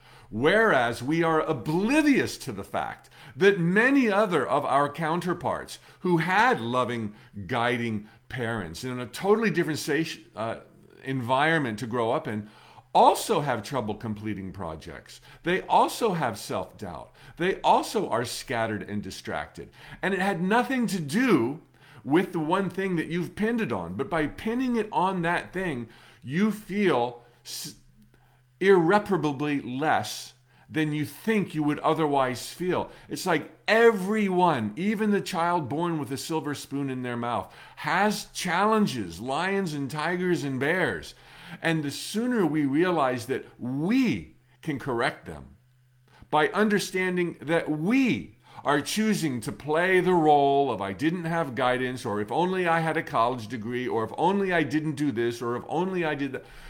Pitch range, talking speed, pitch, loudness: 125-185 Hz, 155 wpm, 155 Hz, -26 LUFS